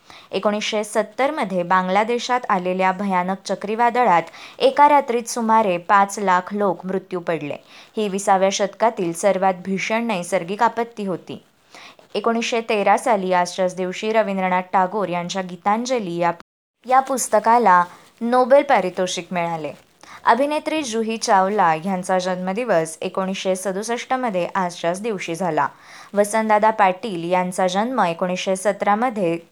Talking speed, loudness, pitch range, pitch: 115 wpm, -20 LUFS, 185-225 Hz, 195 Hz